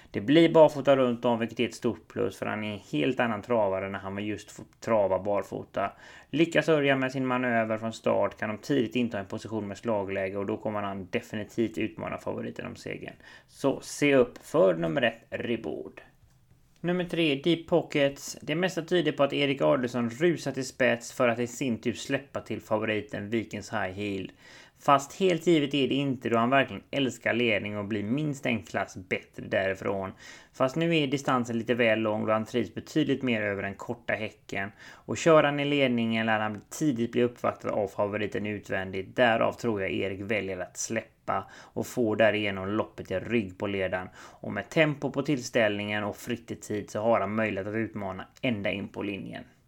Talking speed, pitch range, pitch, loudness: 195 wpm, 105-135 Hz, 115 Hz, -28 LUFS